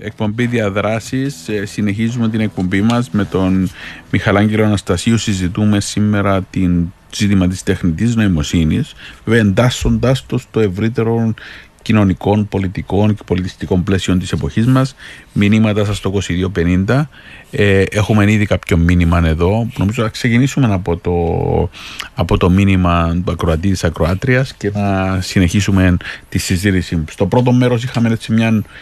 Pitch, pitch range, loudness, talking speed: 100 Hz, 90-110 Hz, -15 LUFS, 130 wpm